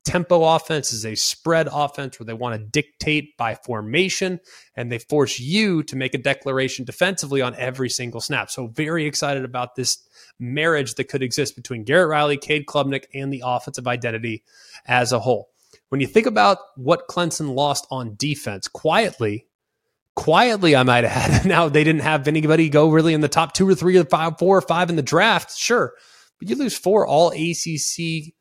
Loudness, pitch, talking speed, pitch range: -20 LUFS, 145 Hz, 190 wpm, 130-165 Hz